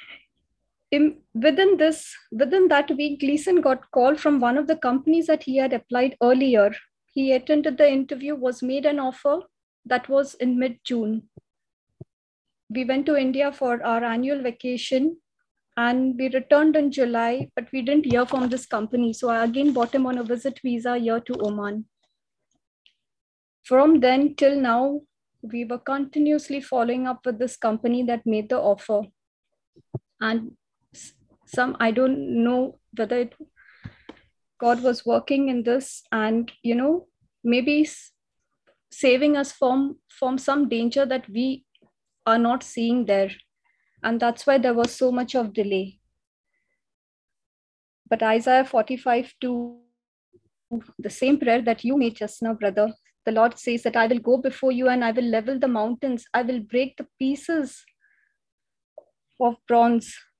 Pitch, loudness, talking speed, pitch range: 255 Hz, -23 LUFS, 150 wpm, 235-280 Hz